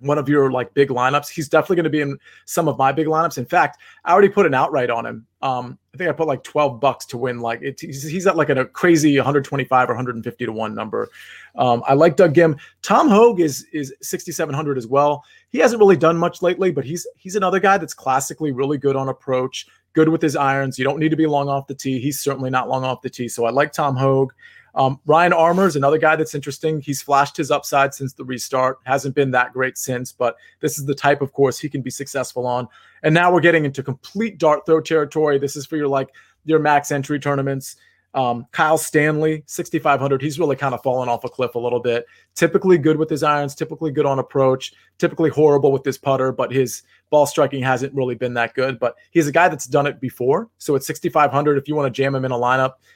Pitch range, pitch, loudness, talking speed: 130-155 Hz, 140 Hz, -19 LUFS, 240 wpm